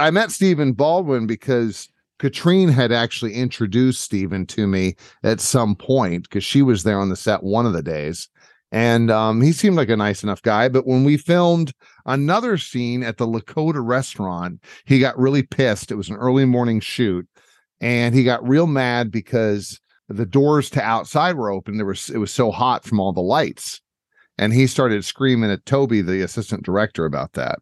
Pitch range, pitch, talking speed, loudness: 105-135 Hz, 120 Hz, 190 wpm, -19 LUFS